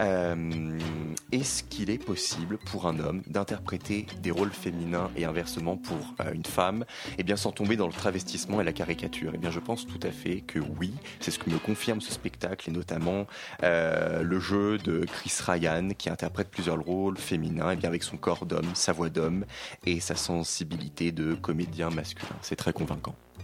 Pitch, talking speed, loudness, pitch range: 85 Hz, 195 wpm, -31 LUFS, 85-95 Hz